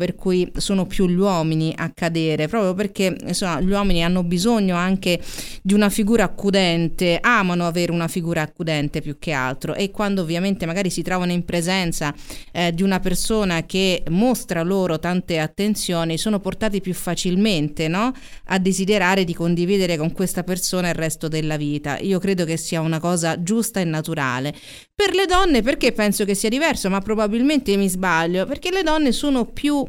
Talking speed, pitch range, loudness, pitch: 175 wpm, 170-205 Hz, -20 LUFS, 185 Hz